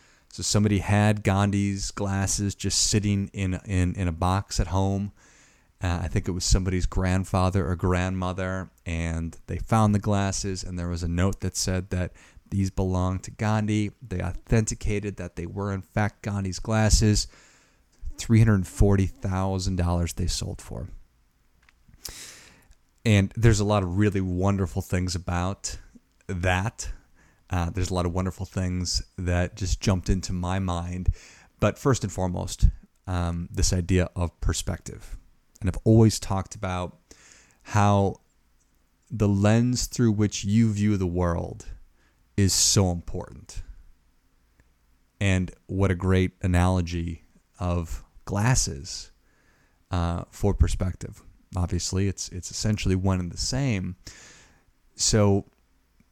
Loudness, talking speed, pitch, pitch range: -26 LUFS, 130 wpm, 95 Hz, 85-100 Hz